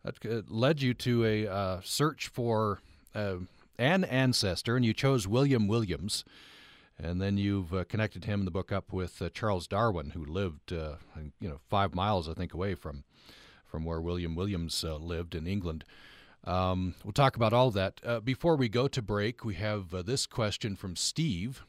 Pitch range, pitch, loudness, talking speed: 90-120 Hz, 100 Hz, -31 LUFS, 195 wpm